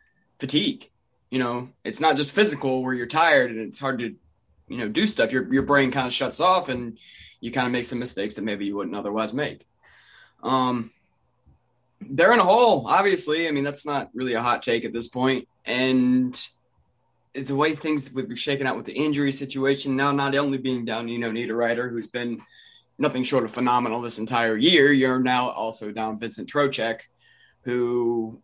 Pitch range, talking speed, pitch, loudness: 115-135 Hz, 195 wpm, 125 Hz, -23 LUFS